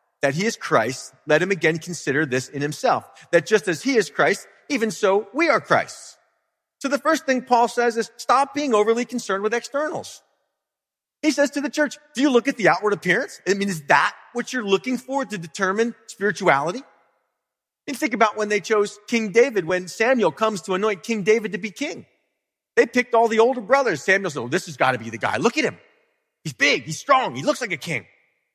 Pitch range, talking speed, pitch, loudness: 180-255 Hz, 225 wpm, 220 Hz, -21 LUFS